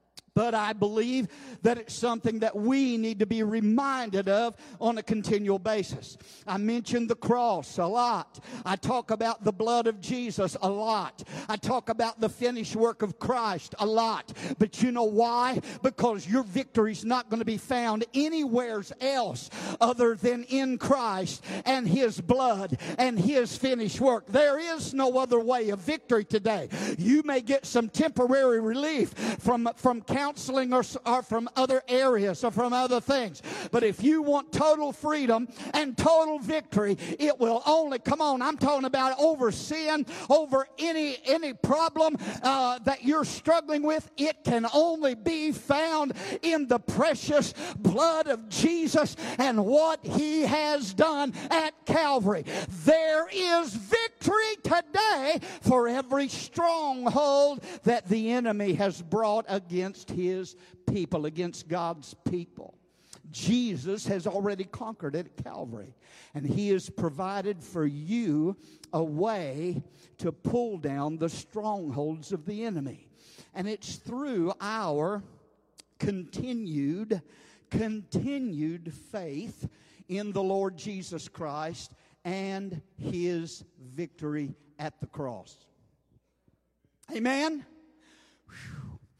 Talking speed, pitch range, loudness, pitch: 135 wpm, 195-270 Hz, -28 LUFS, 230 Hz